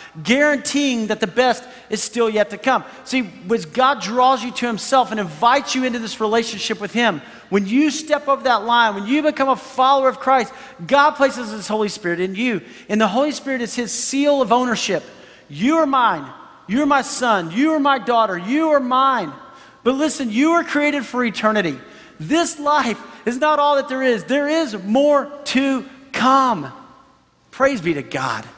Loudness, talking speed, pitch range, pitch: -18 LUFS, 190 wpm, 225-275 Hz, 255 Hz